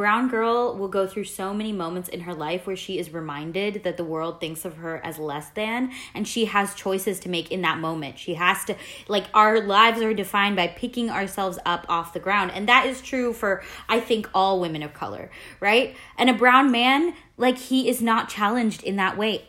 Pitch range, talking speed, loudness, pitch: 175-225 Hz, 220 wpm, -23 LUFS, 200 Hz